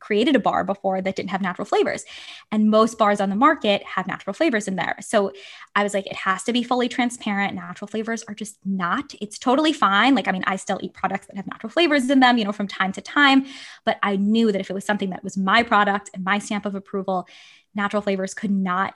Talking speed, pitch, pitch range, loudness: 245 wpm, 205 Hz, 195-225 Hz, -21 LUFS